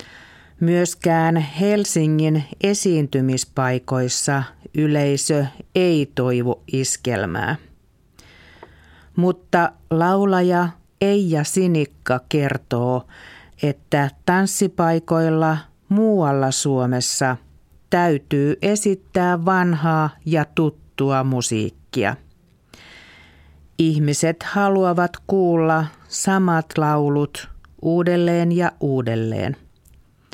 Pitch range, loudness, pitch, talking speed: 130-175 Hz, -20 LUFS, 150 Hz, 60 wpm